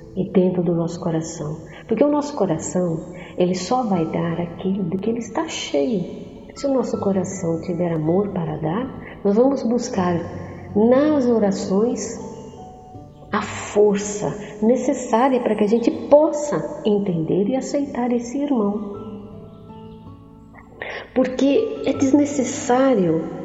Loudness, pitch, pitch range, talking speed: -21 LUFS, 210 Hz, 180-255 Hz, 125 wpm